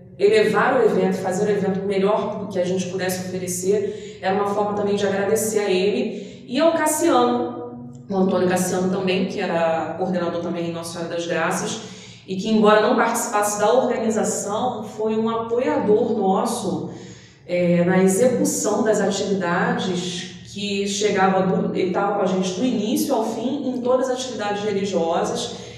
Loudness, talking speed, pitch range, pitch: -21 LUFS, 160 wpm, 185-215 Hz, 200 Hz